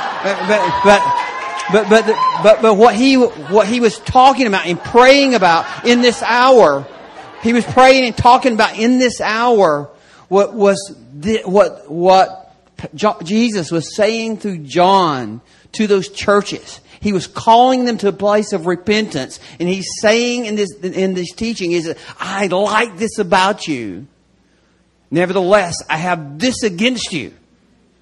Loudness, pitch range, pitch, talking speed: -14 LUFS, 180-230 Hz, 205 Hz, 150 wpm